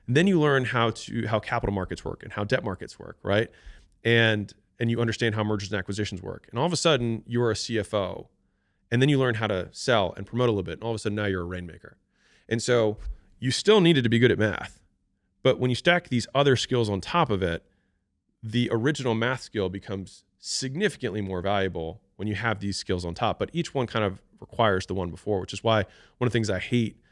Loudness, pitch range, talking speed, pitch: -26 LUFS, 95-120 Hz, 240 wpm, 110 Hz